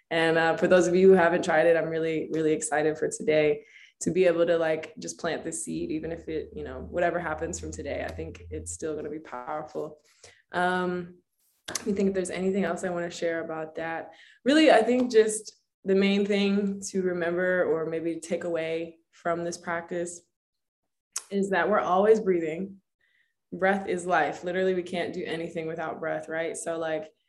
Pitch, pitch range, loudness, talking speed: 170 Hz, 160-185 Hz, -27 LUFS, 195 wpm